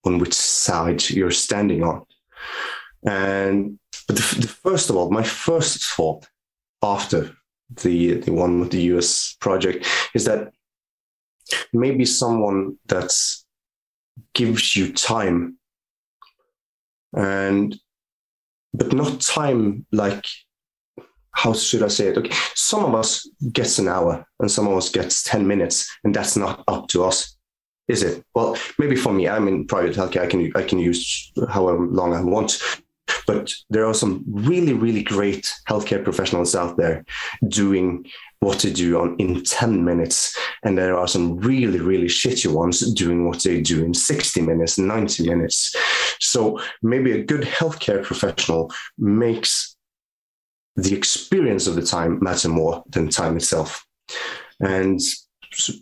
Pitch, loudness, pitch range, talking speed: 95 Hz, -20 LUFS, 85-110 Hz, 145 wpm